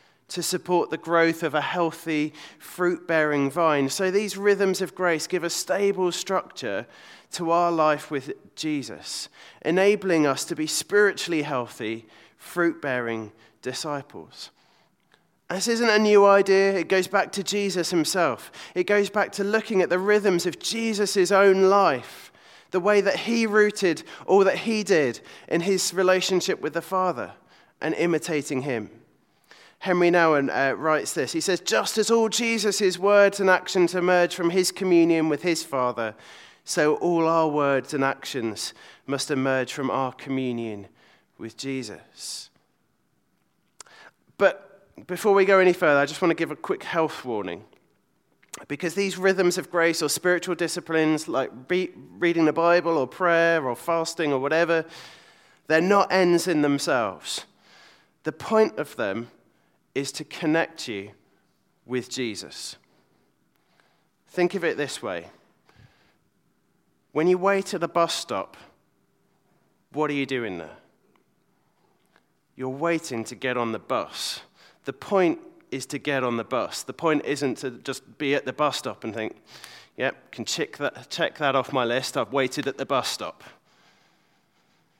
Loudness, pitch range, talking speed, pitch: -24 LUFS, 140-190 Hz, 155 wpm, 170 Hz